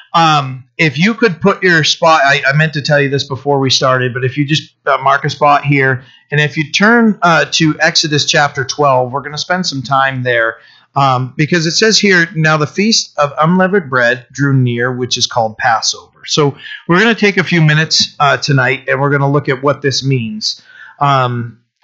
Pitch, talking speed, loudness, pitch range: 145 Hz, 215 wpm, -12 LUFS, 135-160 Hz